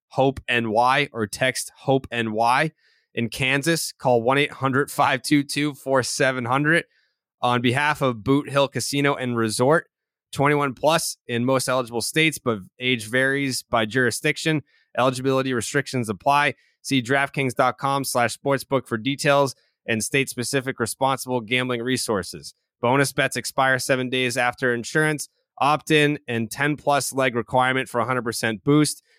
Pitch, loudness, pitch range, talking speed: 130 Hz, -22 LUFS, 120-140 Hz, 130 wpm